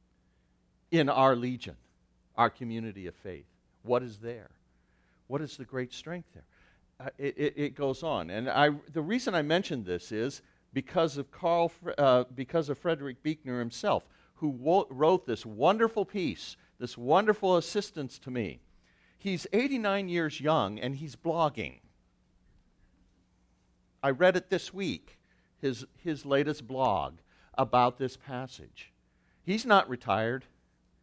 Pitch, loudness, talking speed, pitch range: 130 Hz, -30 LUFS, 140 wpm, 105-160 Hz